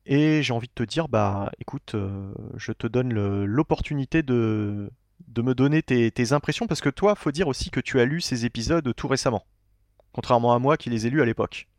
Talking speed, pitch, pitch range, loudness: 225 wpm, 120 Hz, 110-145 Hz, -24 LUFS